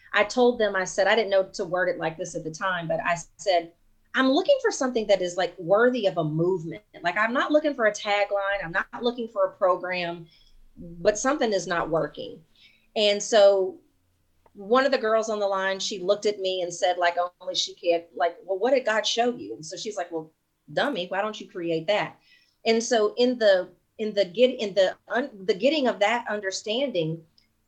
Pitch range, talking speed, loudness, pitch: 175-220 Hz, 215 wpm, -25 LUFS, 195 Hz